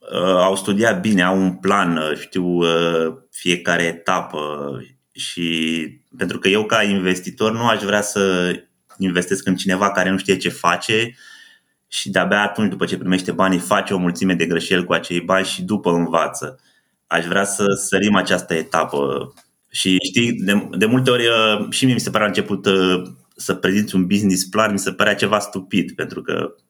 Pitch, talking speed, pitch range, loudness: 95 Hz, 170 wpm, 85-100 Hz, -18 LUFS